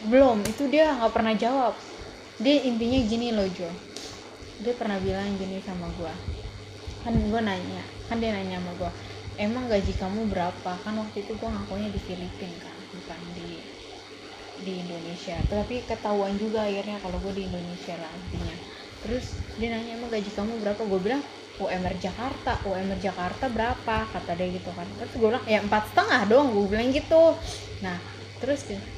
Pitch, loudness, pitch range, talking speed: 210 Hz, -27 LUFS, 190-230 Hz, 170 wpm